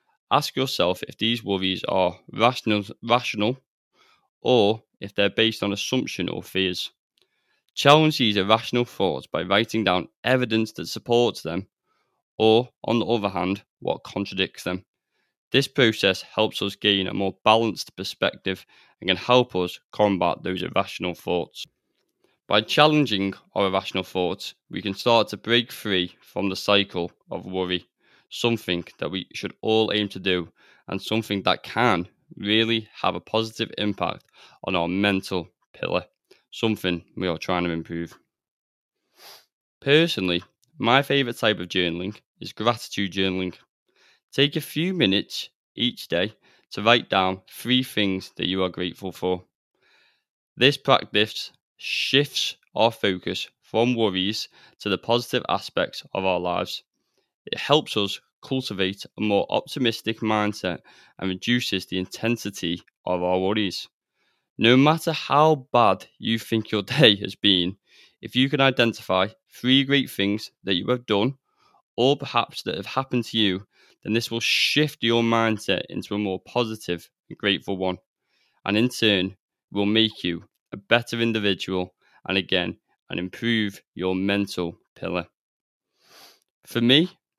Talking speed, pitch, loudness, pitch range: 145 wpm, 105 Hz, -23 LUFS, 95-120 Hz